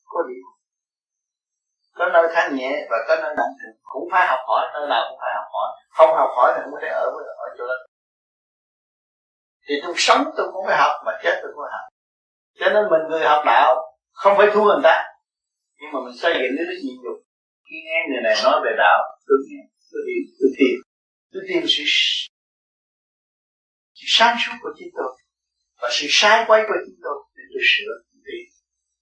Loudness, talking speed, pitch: -19 LUFS, 195 wpm, 270 Hz